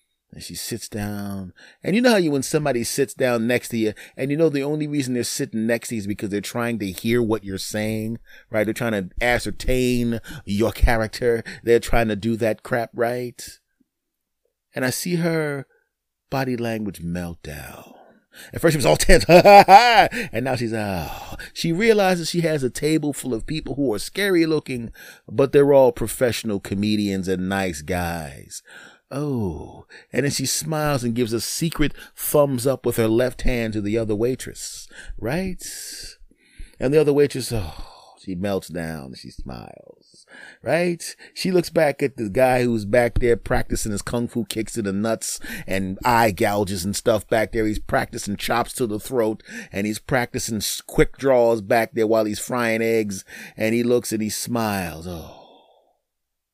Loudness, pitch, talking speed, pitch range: -21 LUFS, 115 Hz, 180 wpm, 105-135 Hz